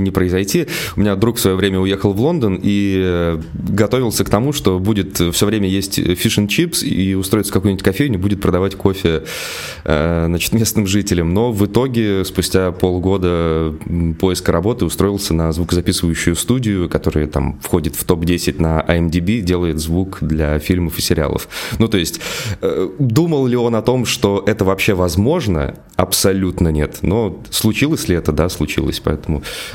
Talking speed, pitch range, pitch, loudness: 155 wpm, 85-105 Hz, 95 Hz, -16 LUFS